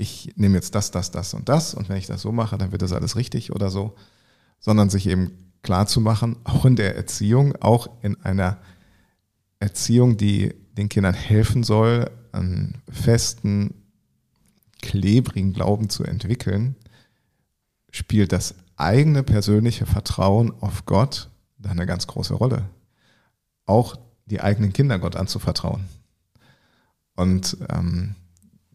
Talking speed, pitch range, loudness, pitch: 130 wpm, 95-115 Hz, -22 LUFS, 105 Hz